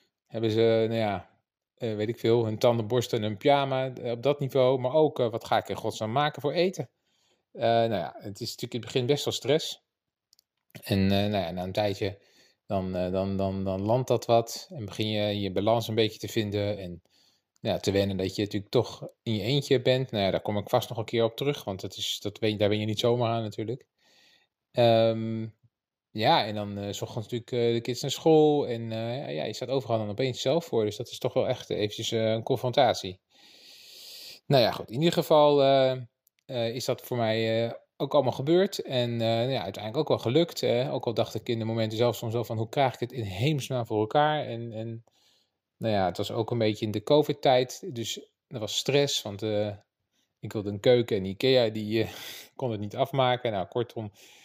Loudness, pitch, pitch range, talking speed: -27 LUFS, 115 Hz, 105-130 Hz, 225 wpm